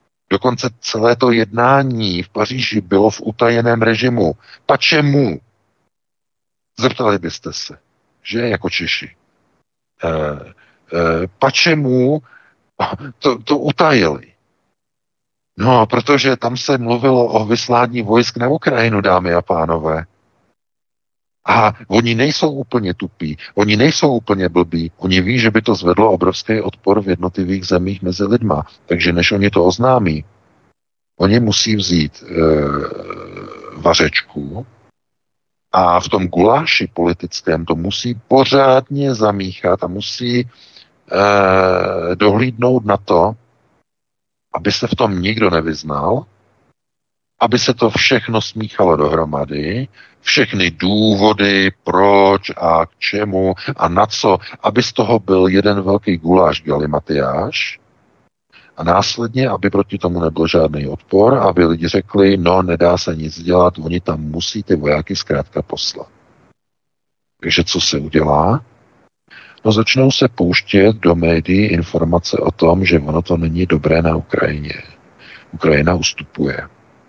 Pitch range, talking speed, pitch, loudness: 85-120 Hz, 120 wpm, 100 Hz, -15 LUFS